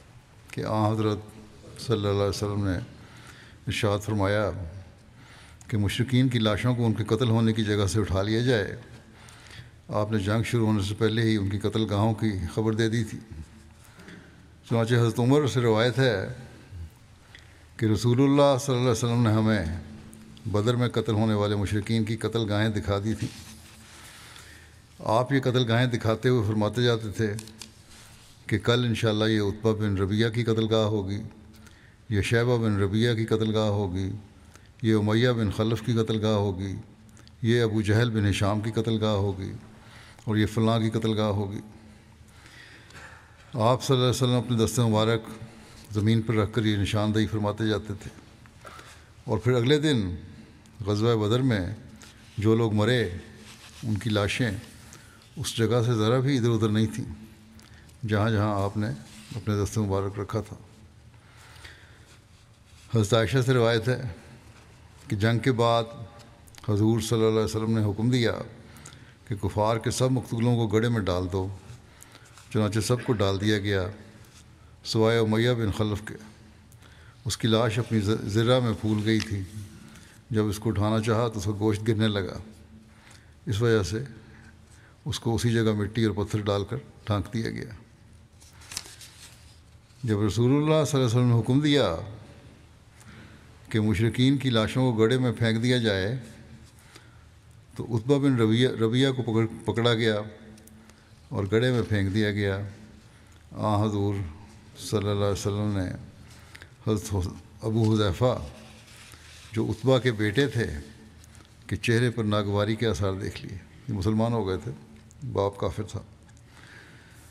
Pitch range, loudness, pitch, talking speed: 105-115 Hz, -26 LUFS, 110 Hz, 155 wpm